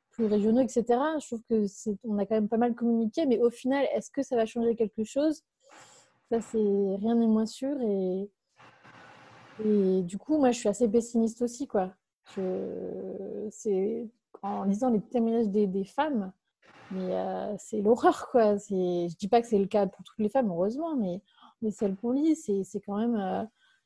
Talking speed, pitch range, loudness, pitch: 195 wpm, 200-240 Hz, -29 LUFS, 220 Hz